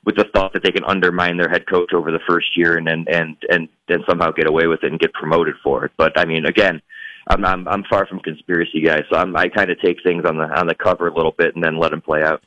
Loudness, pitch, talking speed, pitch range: -17 LUFS, 85 Hz, 300 wpm, 80-90 Hz